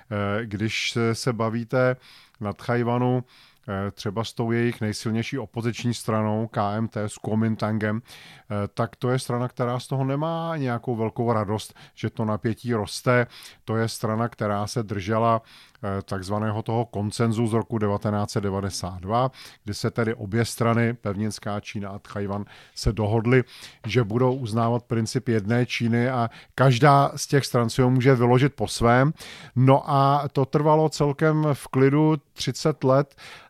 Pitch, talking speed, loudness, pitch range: 115 Hz, 140 wpm, -24 LUFS, 110-130 Hz